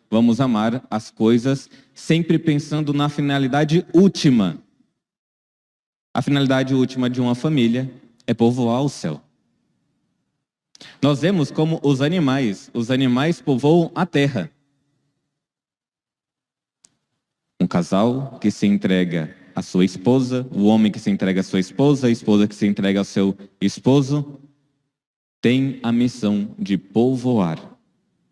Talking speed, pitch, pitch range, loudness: 125 wpm, 130 Hz, 105-145 Hz, -19 LUFS